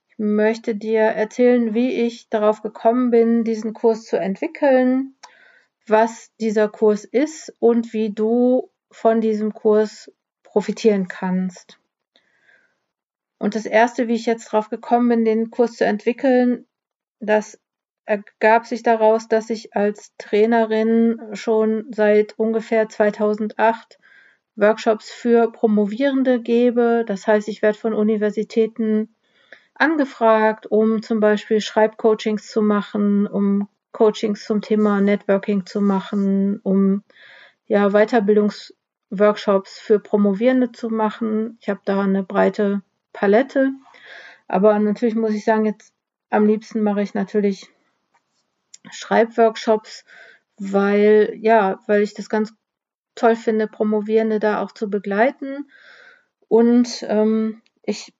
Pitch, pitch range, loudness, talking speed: 220 Hz, 210-230 Hz, -19 LUFS, 120 wpm